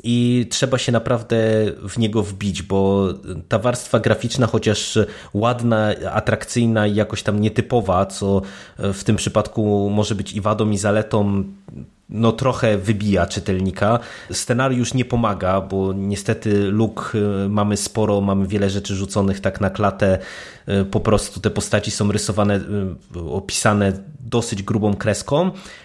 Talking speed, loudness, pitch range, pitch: 130 wpm, -20 LUFS, 100-115 Hz, 105 Hz